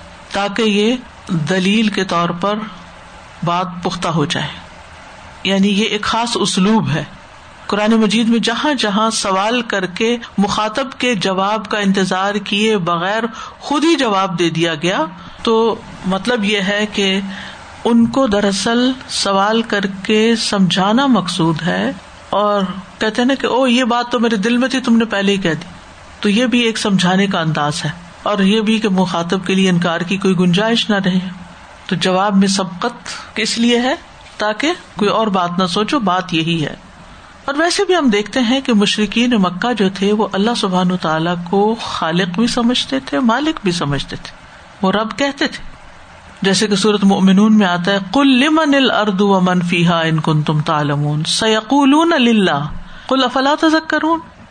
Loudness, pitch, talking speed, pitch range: -15 LUFS, 205 Hz, 170 wpm, 185-230 Hz